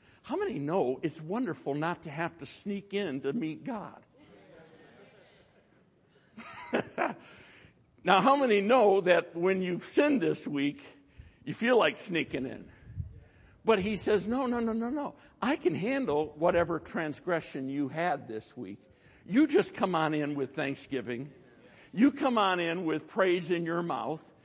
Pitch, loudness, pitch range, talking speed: 170 Hz, -30 LUFS, 145-205 Hz, 150 wpm